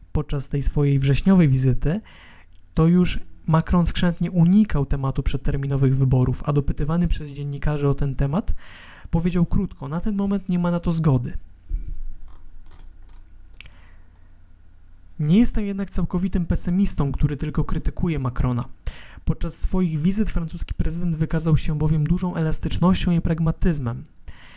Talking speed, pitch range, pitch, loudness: 125 wpm, 125-175 Hz, 150 Hz, -22 LUFS